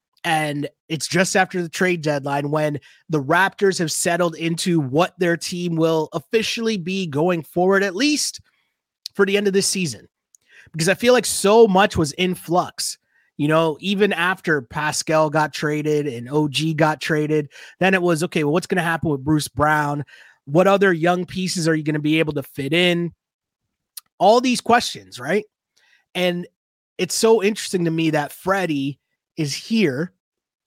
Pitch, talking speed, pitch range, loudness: 170 Hz, 170 wpm, 155-190 Hz, -20 LUFS